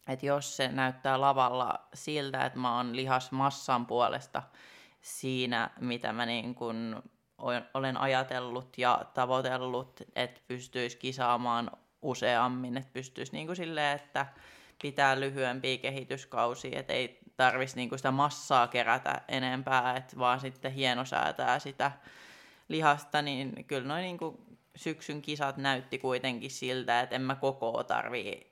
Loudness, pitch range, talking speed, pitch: -32 LUFS, 125-135 Hz, 125 wpm, 130 Hz